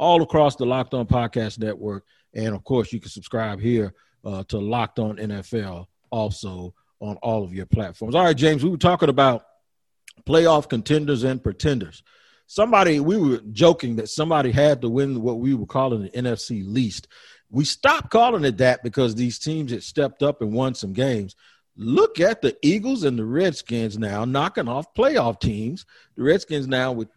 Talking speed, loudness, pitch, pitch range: 185 wpm, -22 LUFS, 125 Hz, 110-145 Hz